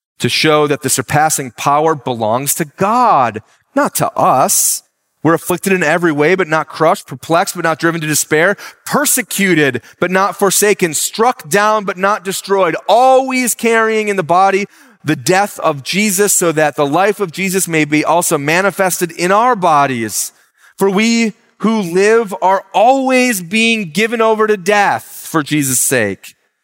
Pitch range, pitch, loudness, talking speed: 155-210 Hz, 190 Hz, -13 LUFS, 160 wpm